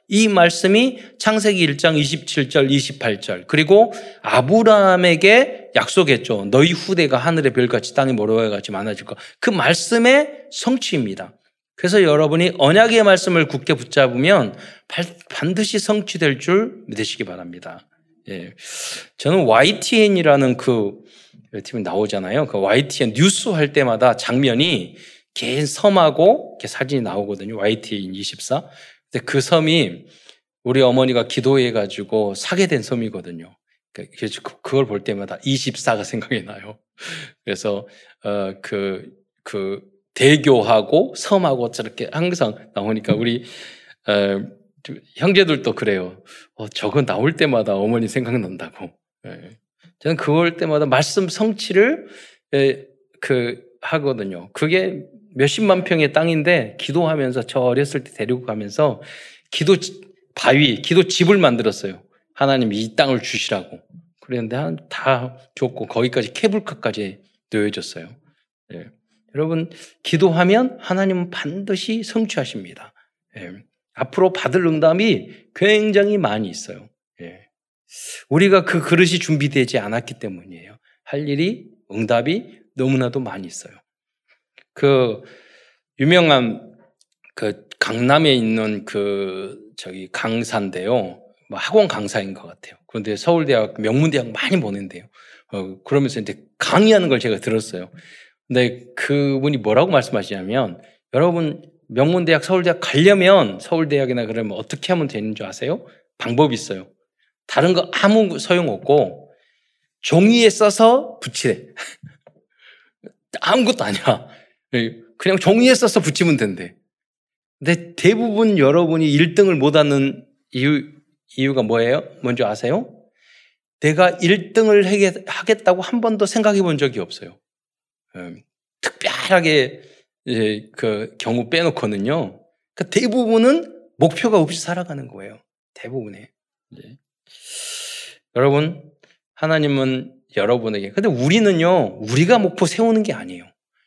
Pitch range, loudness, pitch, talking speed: 115-185 Hz, -18 LUFS, 145 Hz, 270 characters per minute